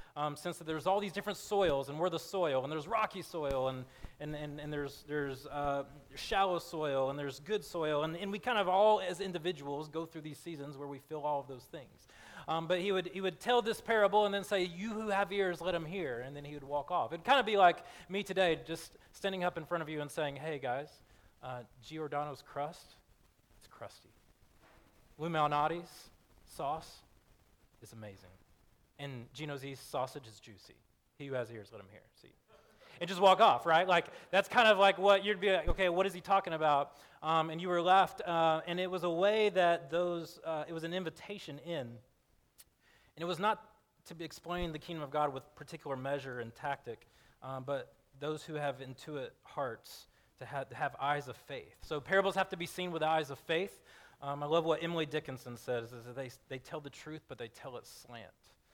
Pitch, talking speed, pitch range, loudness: 155 Hz, 215 wpm, 140-180 Hz, -34 LUFS